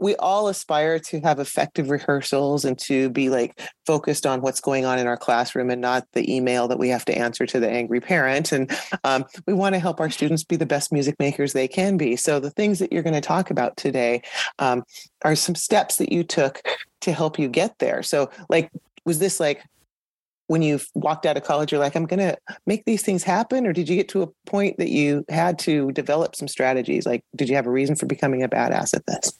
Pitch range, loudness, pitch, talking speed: 130-170 Hz, -22 LUFS, 145 Hz, 235 wpm